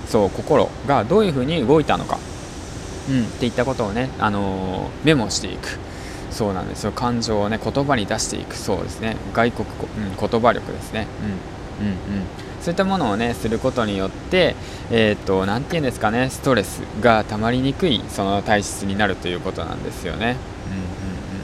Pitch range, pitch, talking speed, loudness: 95-115 Hz, 105 Hz, 390 characters per minute, -21 LUFS